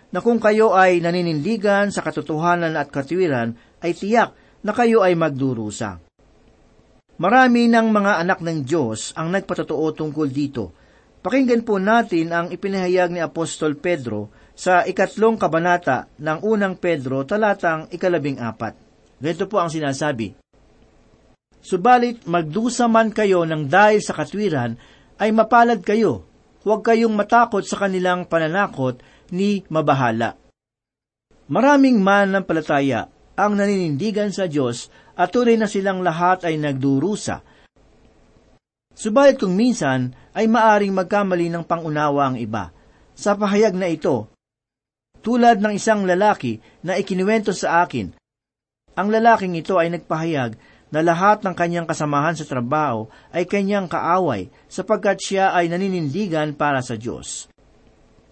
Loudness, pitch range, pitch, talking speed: -19 LUFS, 145-205 Hz, 175 Hz, 130 wpm